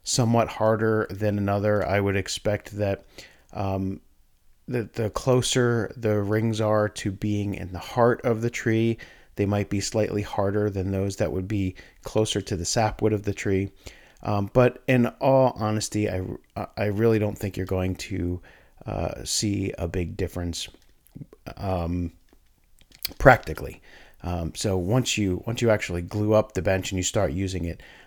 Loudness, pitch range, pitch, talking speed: -25 LUFS, 95-110 Hz, 100 Hz, 165 wpm